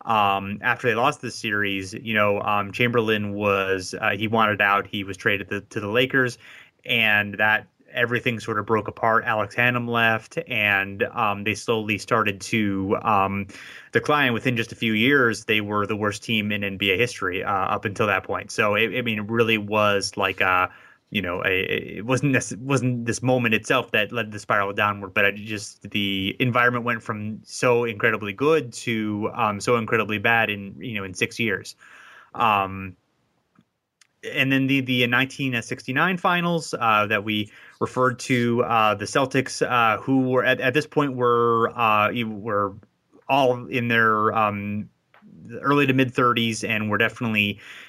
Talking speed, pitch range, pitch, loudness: 175 wpm, 105-125 Hz, 110 Hz, -22 LUFS